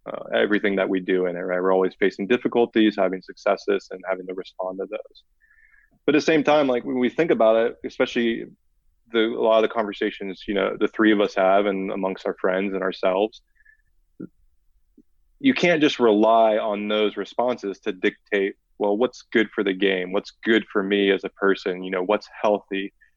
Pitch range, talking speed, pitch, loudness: 95-120 Hz, 200 wpm, 105 Hz, -22 LUFS